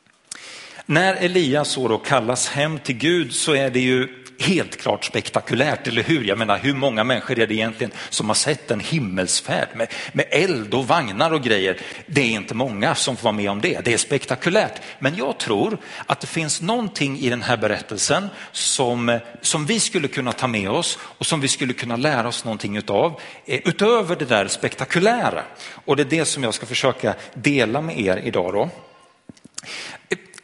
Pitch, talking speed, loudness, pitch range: 130 Hz, 185 wpm, -21 LUFS, 115-155 Hz